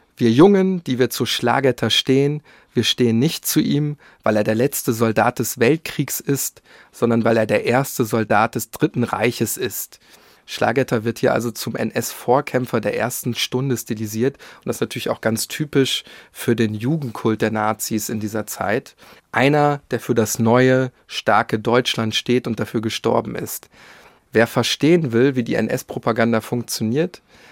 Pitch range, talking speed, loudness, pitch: 115-130 Hz, 160 wpm, -19 LUFS, 120 Hz